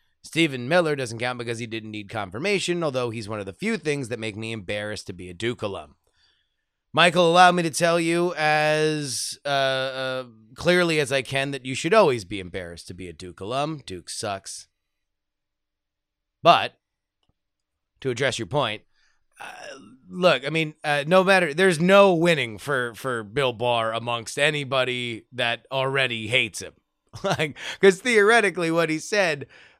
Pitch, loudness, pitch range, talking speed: 130 Hz, -22 LUFS, 115-165 Hz, 165 wpm